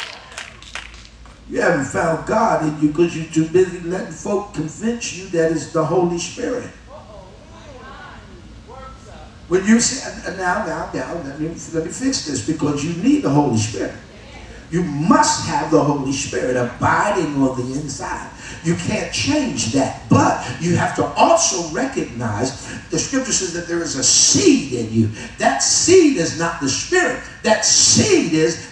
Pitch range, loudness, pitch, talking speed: 140-185 Hz, -18 LUFS, 160 Hz, 160 wpm